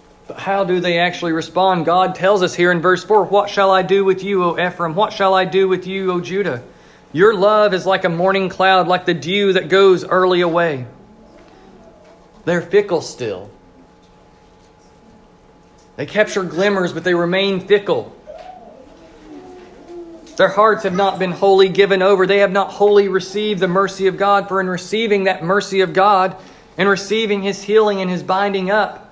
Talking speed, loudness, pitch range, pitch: 175 wpm, -16 LUFS, 180-200 Hz, 190 Hz